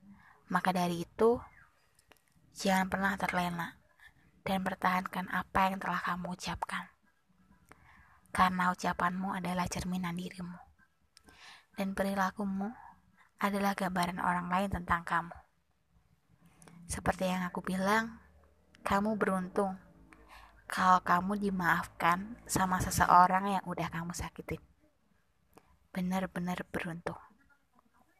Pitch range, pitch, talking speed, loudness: 180-195 Hz, 185 Hz, 90 wpm, -32 LUFS